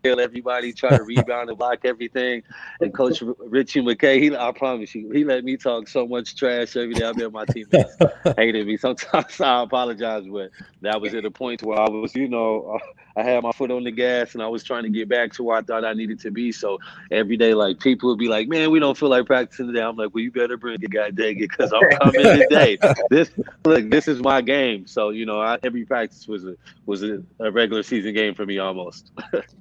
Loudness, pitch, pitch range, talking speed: -20 LUFS, 120 Hz, 110-125 Hz, 240 wpm